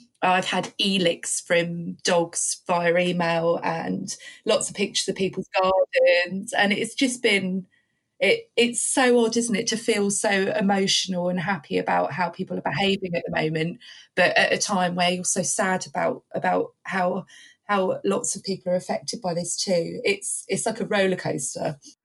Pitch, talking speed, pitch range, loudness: 190 Hz, 170 wpm, 175-215 Hz, -23 LUFS